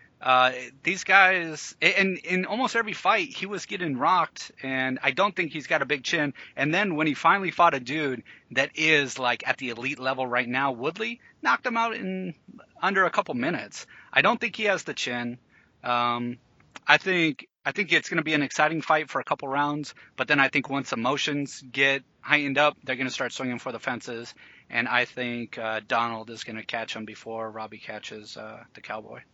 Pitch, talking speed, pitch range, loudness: 140 Hz, 210 wpm, 125-165 Hz, -25 LUFS